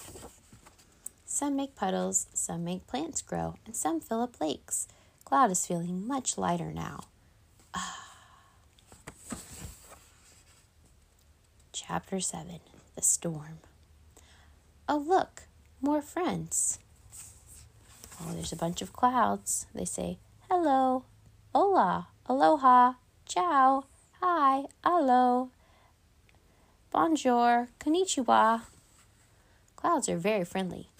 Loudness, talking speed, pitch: -29 LUFS, 90 wpm, 165 Hz